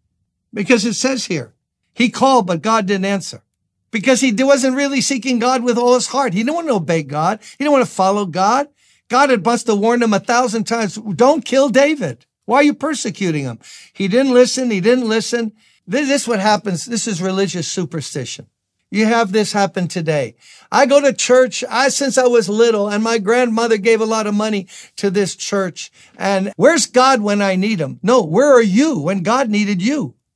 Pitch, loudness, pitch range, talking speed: 225 Hz, -16 LUFS, 195-255 Hz, 200 wpm